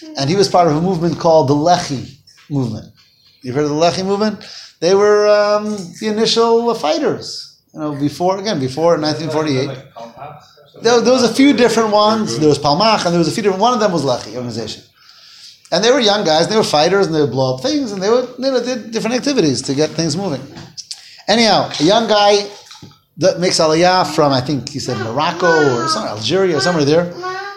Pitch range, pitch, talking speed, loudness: 150-215 Hz, 175 Hz, 210 wpm, -15 LUFS